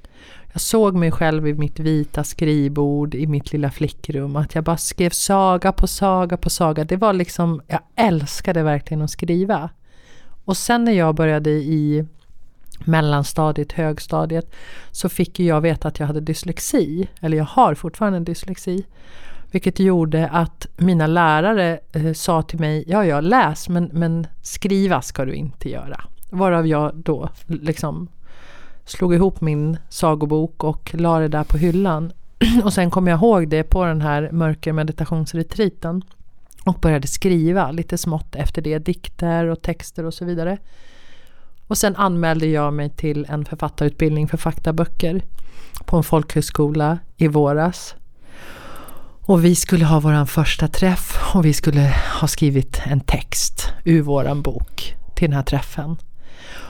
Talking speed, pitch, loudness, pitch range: 150 wpm, 160 Hz, -19 LUFS, 150-180 Hz